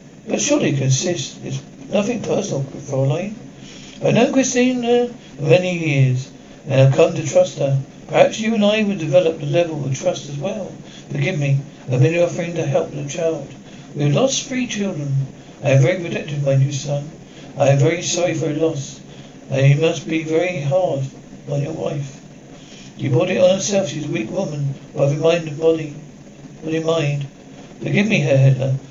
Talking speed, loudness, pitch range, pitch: 195 wpm, -19 LUFS, 140-180 Hz, 155 Hz